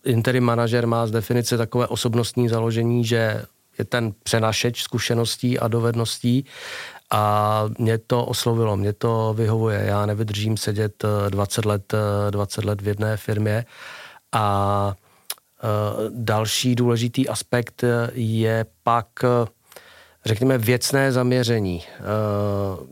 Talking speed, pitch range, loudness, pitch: 105 wpm, 105-120 Hz, -22 LUFS, 115 Hz